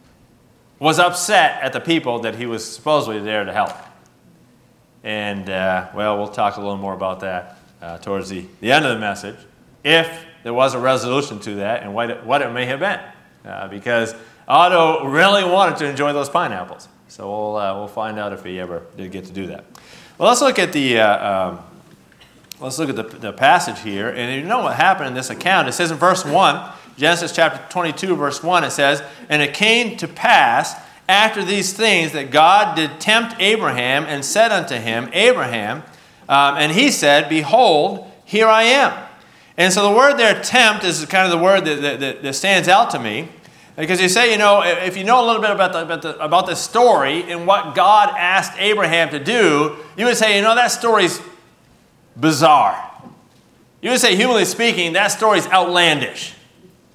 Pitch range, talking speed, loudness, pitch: 120-195 Hz, 200 wpm, -16 LUFS, 160 Hz